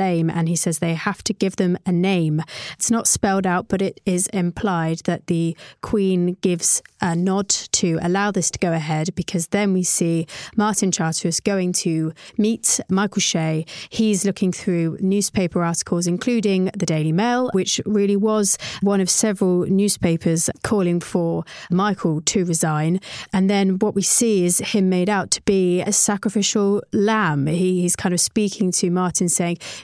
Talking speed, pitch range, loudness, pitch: 170 wpm, 170-200 Hz, -20 LUFS, 185 Hz